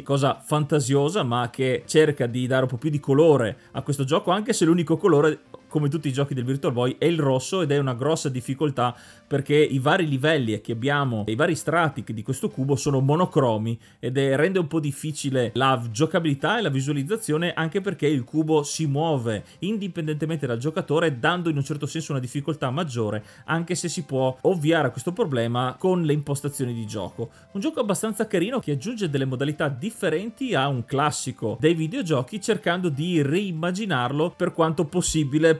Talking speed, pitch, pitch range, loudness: 185 wpm, 150 Hz, 130-165 Hz, -24 LUFS